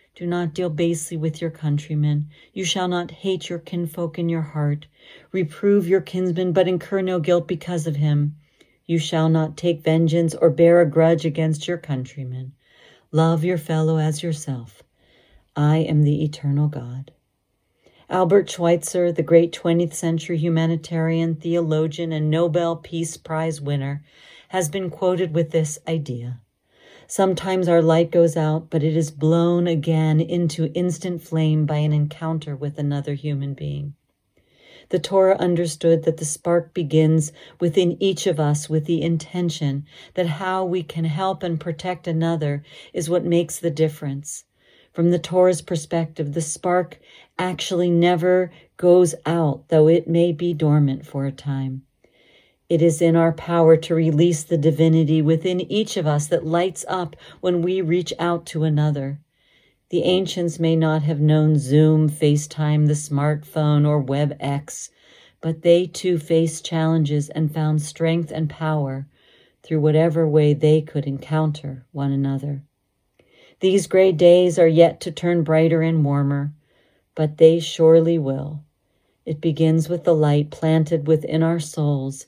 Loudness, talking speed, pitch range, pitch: -20 LUFS, 150 wpm, 150-170 Hz, 160 Hz